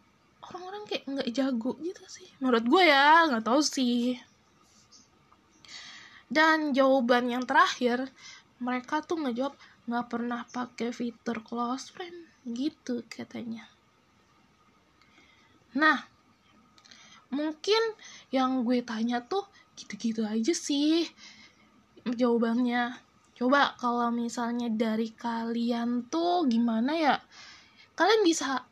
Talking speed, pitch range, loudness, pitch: 100 wpm, 240-310 Hz, -28 LUFS, 250 Hz